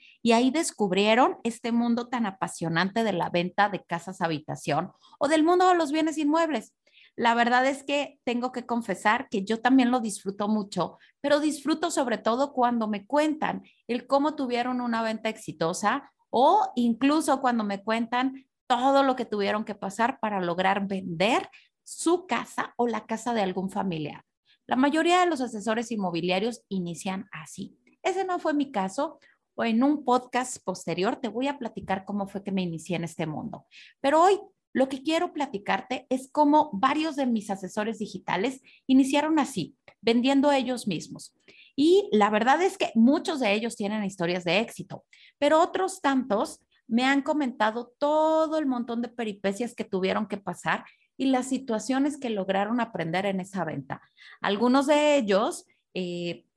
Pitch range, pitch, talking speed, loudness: 200-280 Hz, 240 Hz, 165 wpm, -26 LUFS